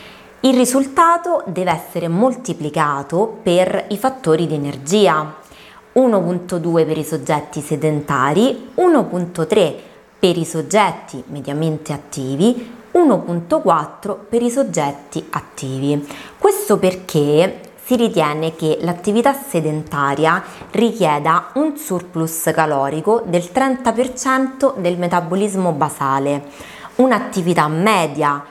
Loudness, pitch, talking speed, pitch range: -17 LUFS, 175 Hz, 95 wpm, 155-230 Hz